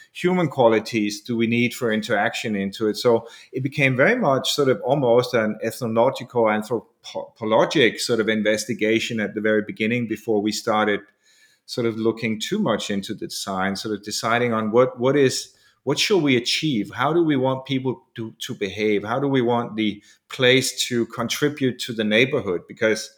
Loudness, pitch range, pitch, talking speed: -21 LUFS, 105-130 Hz, 115 Hz, 180 wpm